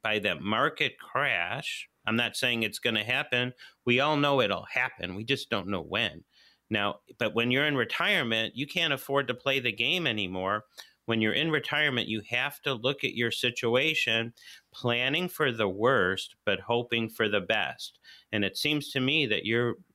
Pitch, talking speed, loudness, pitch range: 120 Hz, 185 wpm, -28 LUFS, 115-140 Hz